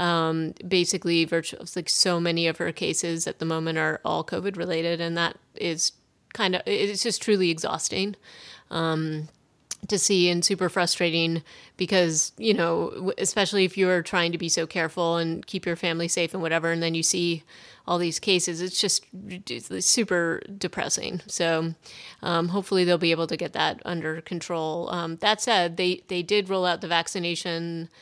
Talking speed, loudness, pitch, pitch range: 175 wpm, -25 LUFS, 175 Hz, 165-185 Hz